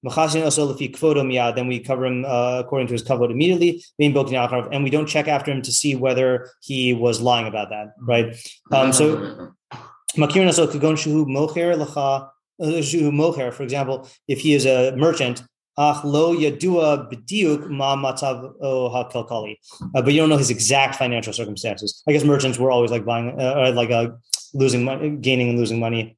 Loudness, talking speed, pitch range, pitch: -20 LUFS, 135 wpm, 125-150 Hz, 135 Hz